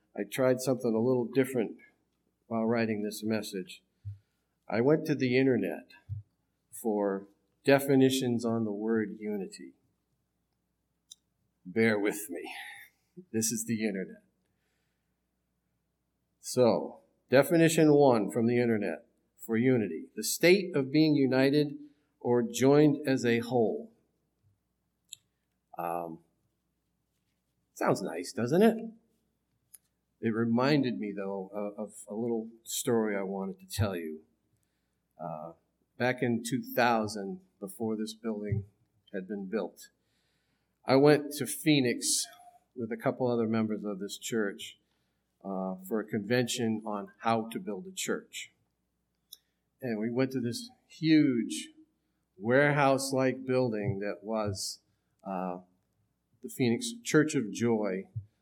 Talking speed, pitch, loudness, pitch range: 115 wpm, 115 Hz, -30 LUFS, 100-130 Hz